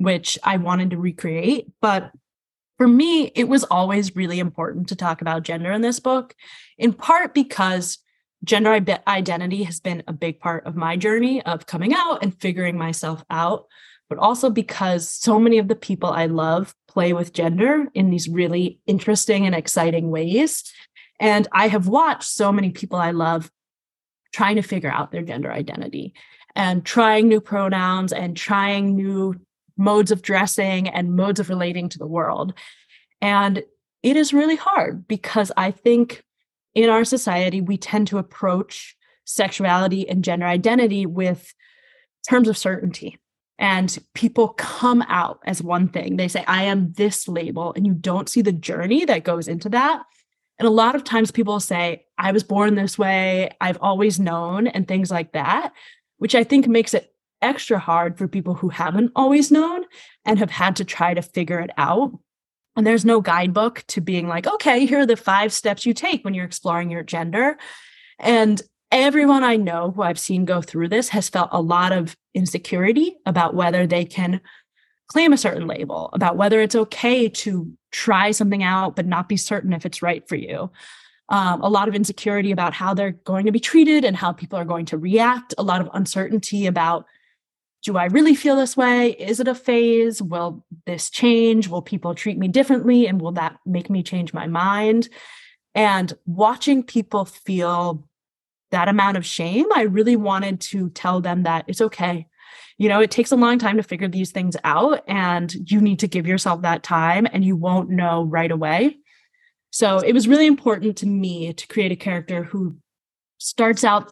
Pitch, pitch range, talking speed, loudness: 195 Hz, 175-225 Hz, 185 wpm, -20 LUFS